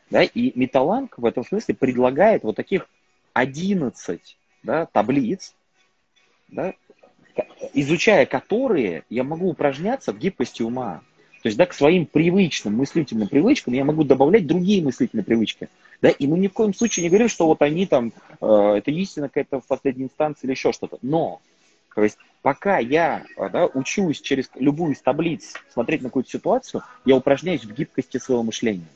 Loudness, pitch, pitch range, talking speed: -21 LUFS, 145 Hz, 130-185 Hz, 165 wpm